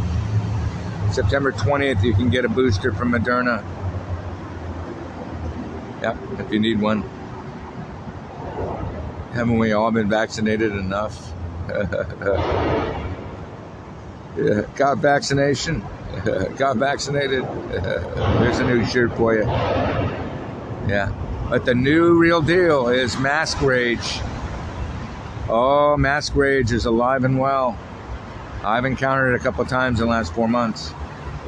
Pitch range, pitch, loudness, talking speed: 100-130 Hz, 115 Hz, -21 LUFS, 110 wpm